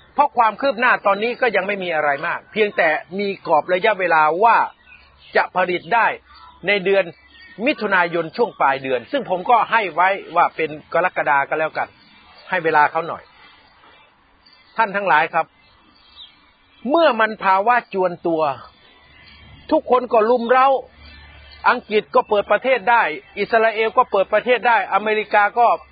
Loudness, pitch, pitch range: -18 LUFS, 205 Hz, 175-235 Hz